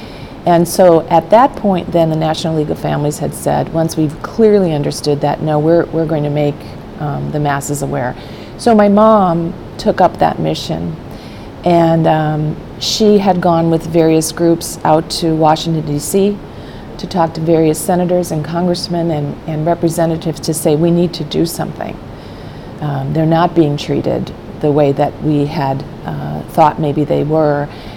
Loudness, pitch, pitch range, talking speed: -14 LUFS, 160 Hz, 150-170 Hz, 170 wpm